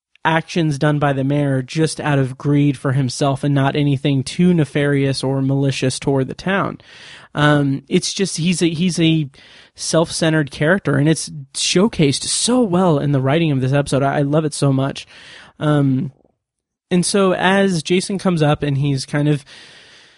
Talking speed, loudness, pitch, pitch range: 170 wpm, -17 LUFS, 150 Hz, 140-165 Hz